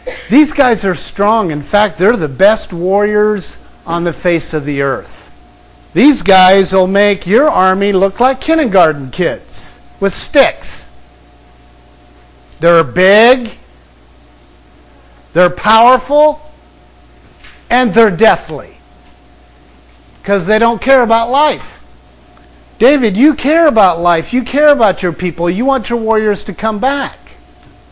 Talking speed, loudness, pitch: 125 wpm, -11 LUFS, 185 Hz